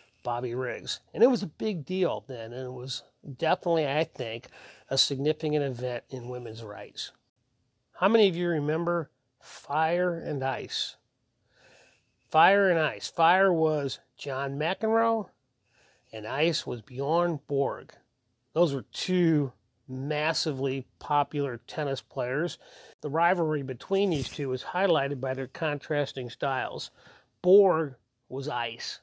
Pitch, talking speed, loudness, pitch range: 140 Hz, 130 wpm, -28 LUFS, 130-165 Hz